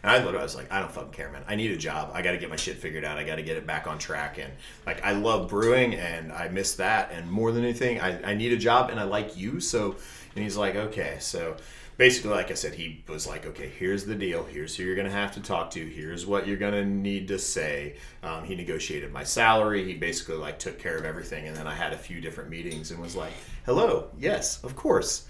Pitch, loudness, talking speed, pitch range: 100 Hz, -28 LUFS, 260 wpm, 85-105 Hz